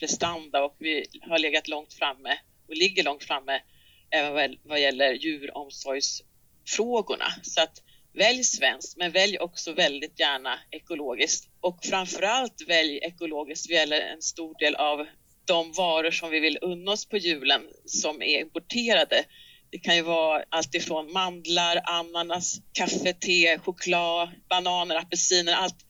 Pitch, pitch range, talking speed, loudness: 170 Hz, 155-180 Hz, 140 wpm, -25 LUFS